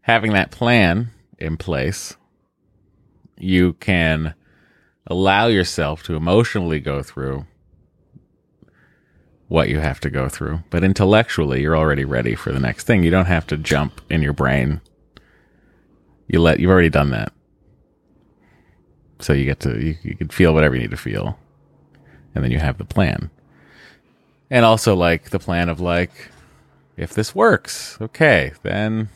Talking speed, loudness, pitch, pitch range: 150 wpm, -18 LUFS, 85 Hz, 75-95 Hz